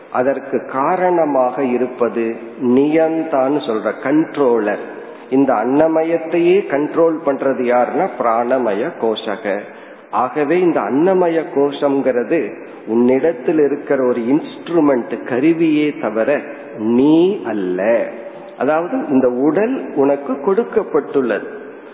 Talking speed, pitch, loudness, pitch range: 80 wpm, 140 Hz, -16 LUFS, 125-165 Hz